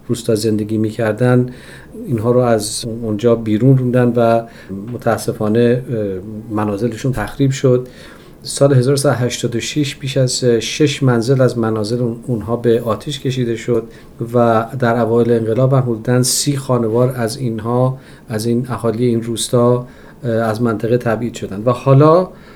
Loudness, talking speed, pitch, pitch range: -16 LUFS, 130 wpm, 120 Hz, 115-125 Hz